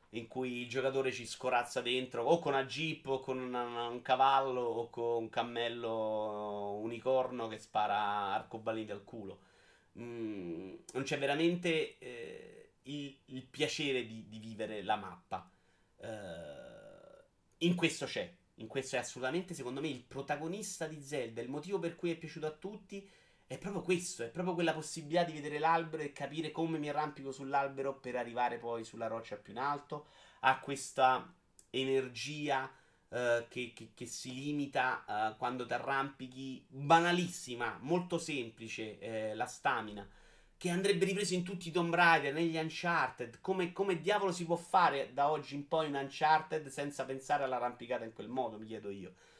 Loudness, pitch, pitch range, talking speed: -36 LUFS, 135 Hz, 120-160 Hz, 165 wpm